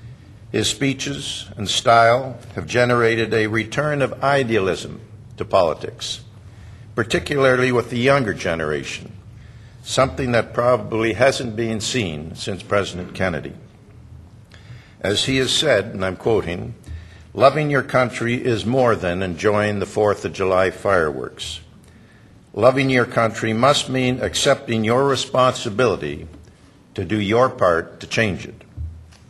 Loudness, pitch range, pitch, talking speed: -19 LUFS, 100-125 Hz, 115 Hz, 125 wpm